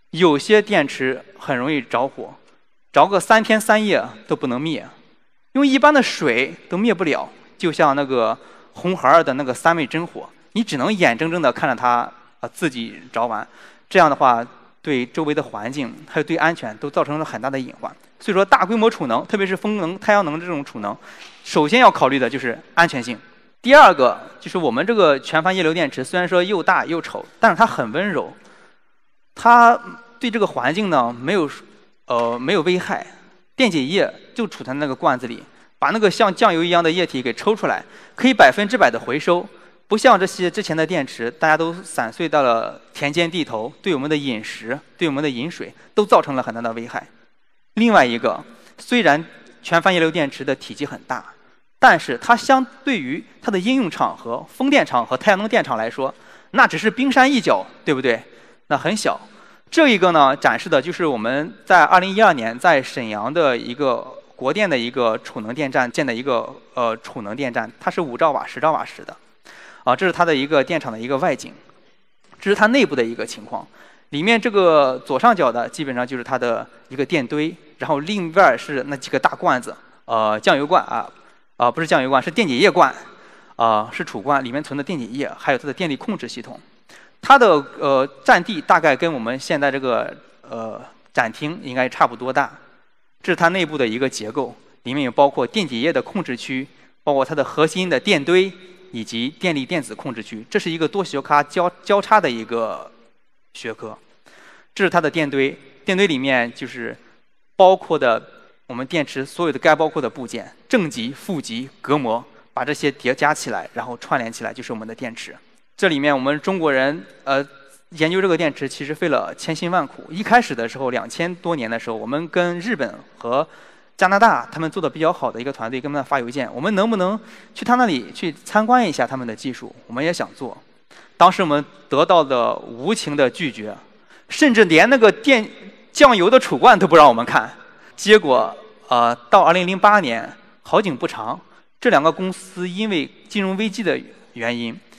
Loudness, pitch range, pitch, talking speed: -18 LUFS, 135-215 Hz, 170 Hz, 290 characters per minute